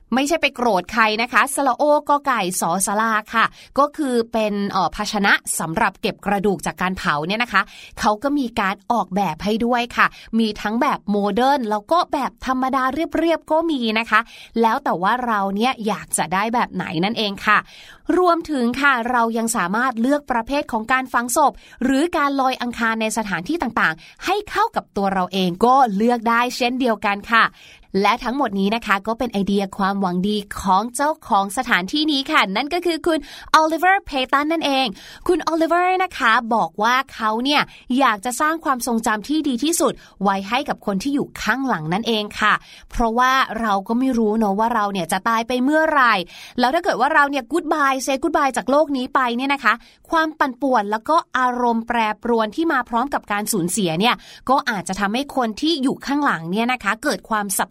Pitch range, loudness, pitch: 210-280 Hz, -19 LUFS, 235 Hz